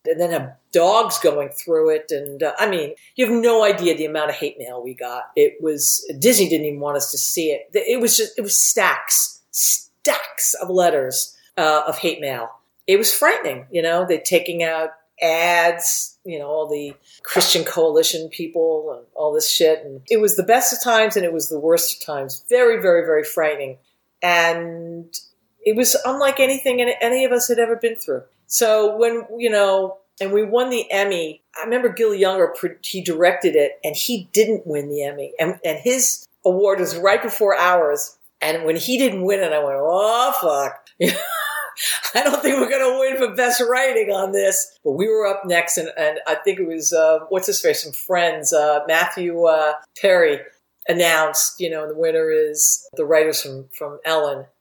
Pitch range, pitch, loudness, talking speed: 160-255 Hz, 195 Hz, -18 LUFS, 195 wpm